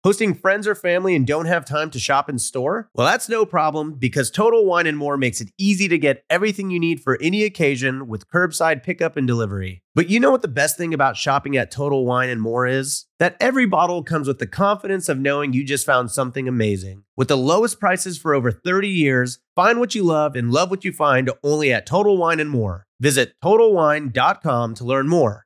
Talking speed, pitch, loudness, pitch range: 220 wpm, 150 Hz, -19 LUFS, 130-180 Hz